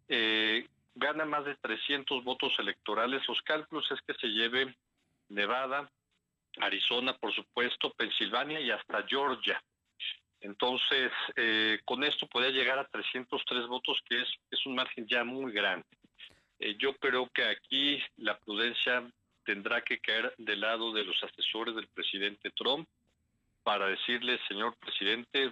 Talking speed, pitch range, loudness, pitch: 140 wpm, 110-135 Hz, -32 LUFS, 125 Hz